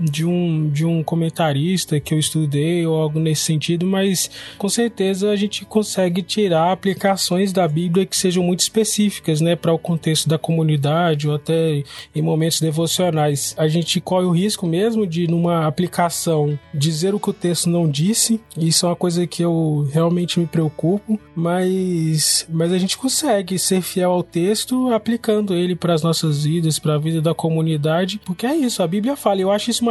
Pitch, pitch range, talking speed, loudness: 170 Hz, 160-190 Hz, 185 wpm, -19 LUFS